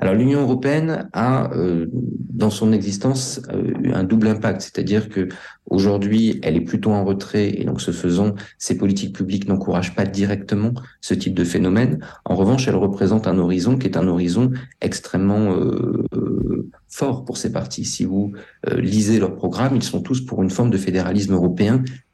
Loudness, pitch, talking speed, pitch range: -20 LUFS, 100 Hz, 175 wpm, 95-120 Hz